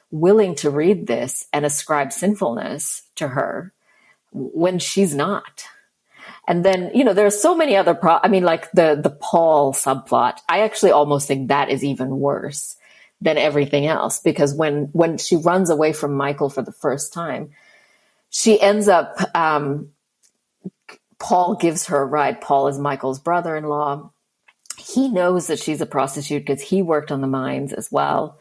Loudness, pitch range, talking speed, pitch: -19 LUFS, 145-180 Hz, 170 wpm, 155 Hz